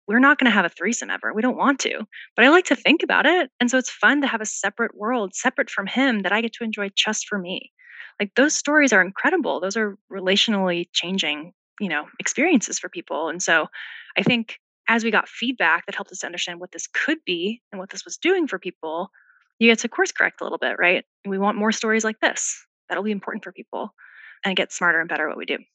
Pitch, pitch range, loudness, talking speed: 220 Hz, 195-260 Hz, -21 LUFS, 245 wpm